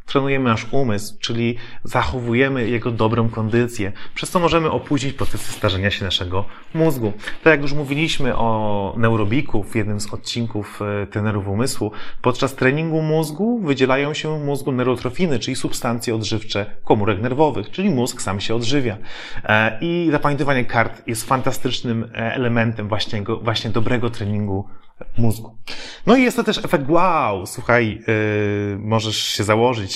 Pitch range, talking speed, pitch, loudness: 110-140 Hz, 140 wpm, 115 Hz, -20 LUFS